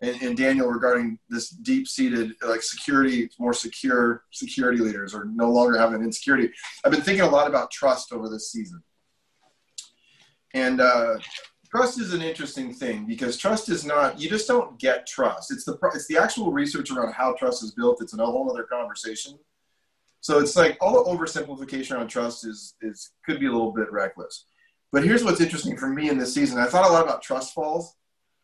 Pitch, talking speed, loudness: 150 Hz, 190 wpm, -23 LUFS